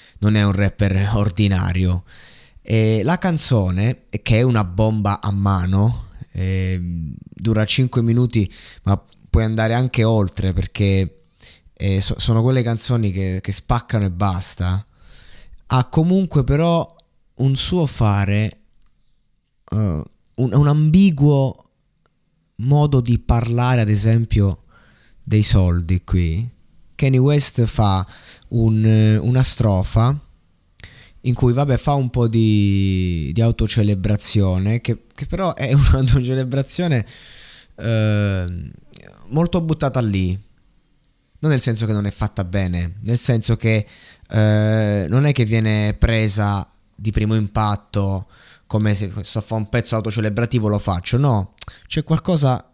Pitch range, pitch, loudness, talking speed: 100-125 Hz, 110 Hz, -18 LUFS, 125 wpm